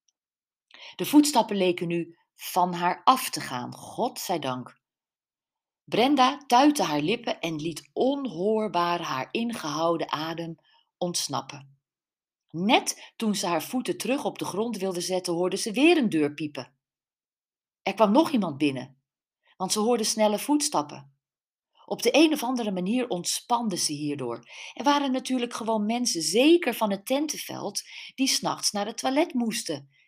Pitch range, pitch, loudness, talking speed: 165-245 Hz, 195 Hz, -26 LUFS, 150 wpm